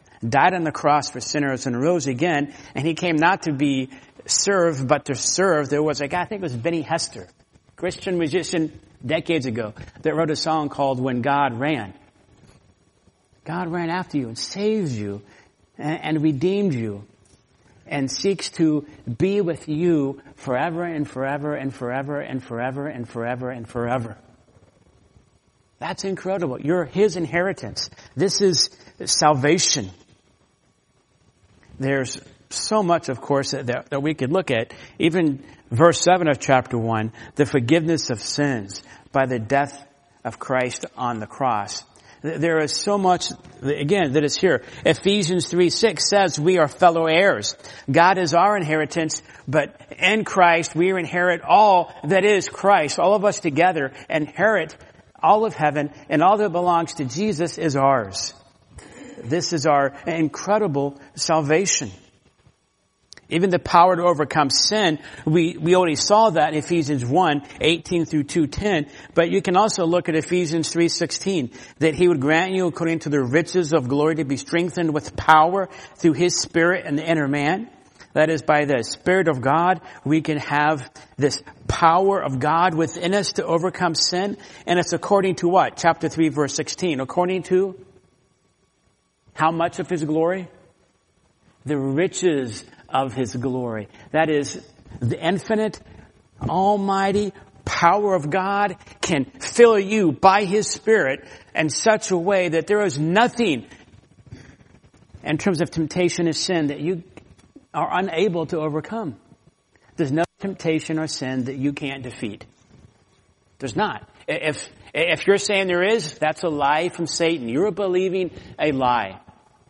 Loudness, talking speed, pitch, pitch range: -21 LUFS, 155 wpm, 155 Hz, 135-175 Hz